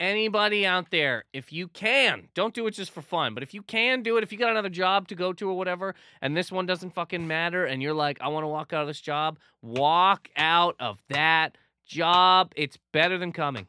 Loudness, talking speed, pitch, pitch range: -25 LUFS, 235 wpm, 180 Hz, 155-195 Hz